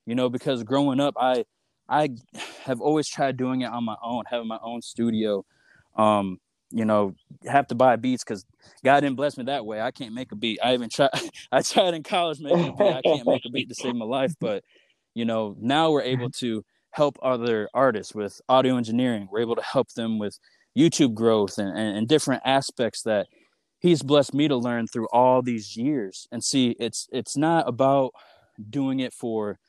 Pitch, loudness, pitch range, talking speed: 125 Hz, -24 LUFS, 115-140 Hz, 200 wpm